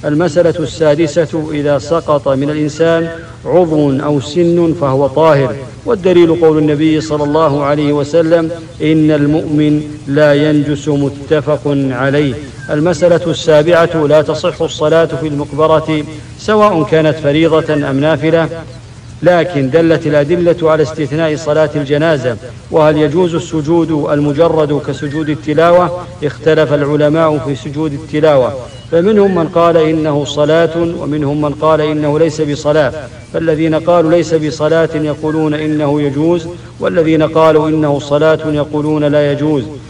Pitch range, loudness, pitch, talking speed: 145-165 Hz, -12 LUFS, 155 Hz, 120 wpm